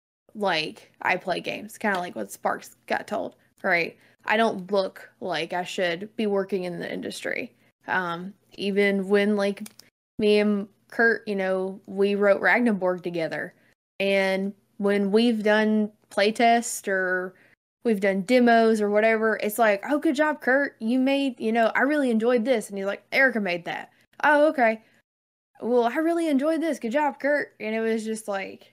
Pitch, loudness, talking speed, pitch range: 215 Hz, -24 LUFS, 170 wpm, 195-240 Hz